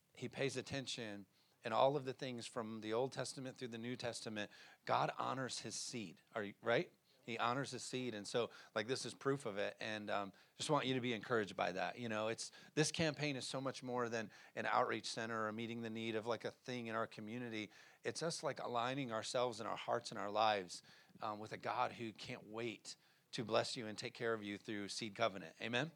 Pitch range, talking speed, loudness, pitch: 110-130 Hz, 230 wpm, -42 LUFS, 115 Hz